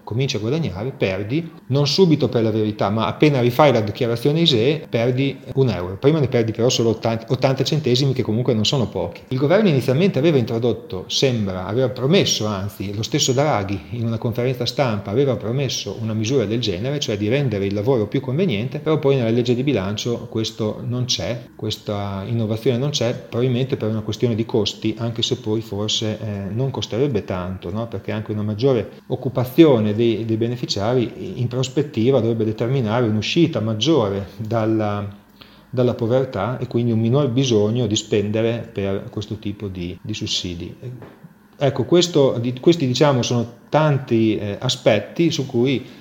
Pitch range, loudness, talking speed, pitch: 110-135 Hz, -20 LUFS, 165 wpm, 120 Hz